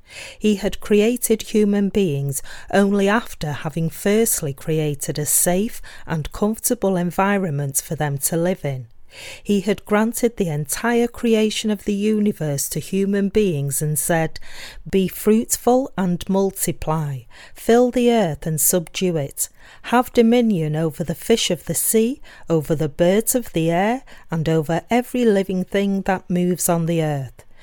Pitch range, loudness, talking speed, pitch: 160-215 Hz, -20 LUFS, 150 wpm, 185 Hz